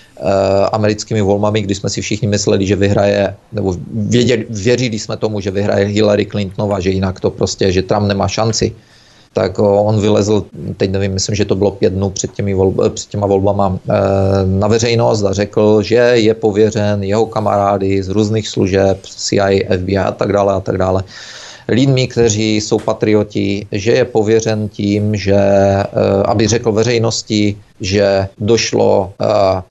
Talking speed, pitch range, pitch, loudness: 155 wpm, 100-110 Hz, 105 Hz, -14 LUFS